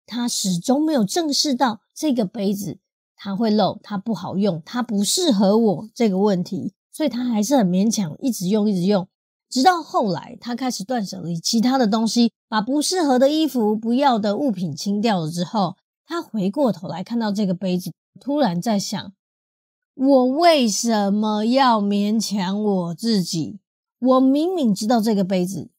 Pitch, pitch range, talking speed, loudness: 215 Hz, 195-255 Hz, 250 characters per minute, -20 LUFS